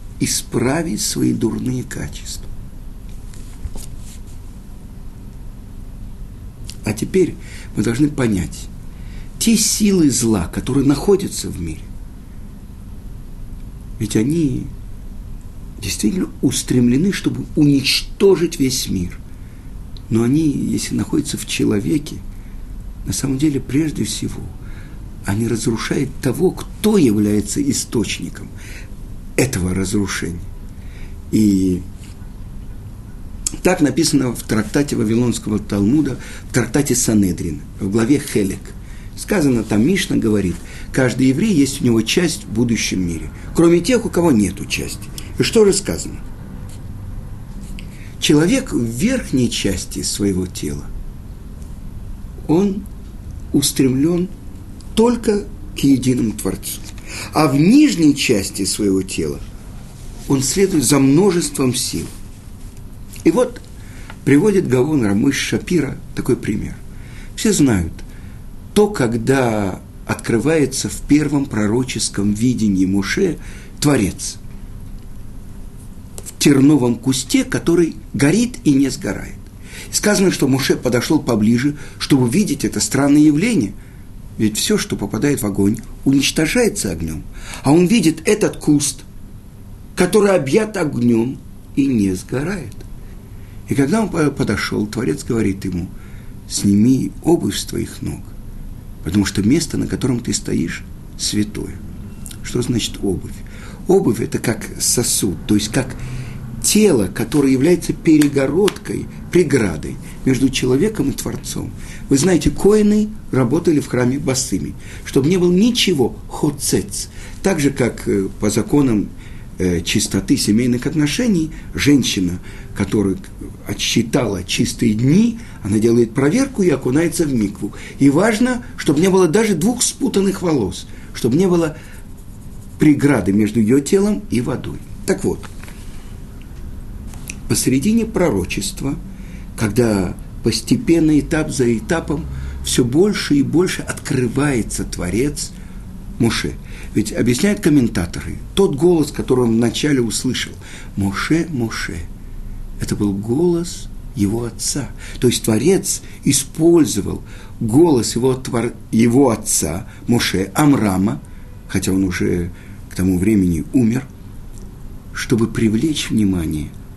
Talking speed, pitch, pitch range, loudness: 105 wpm, 110 Hz, 100-140 Hz, -17 LUFS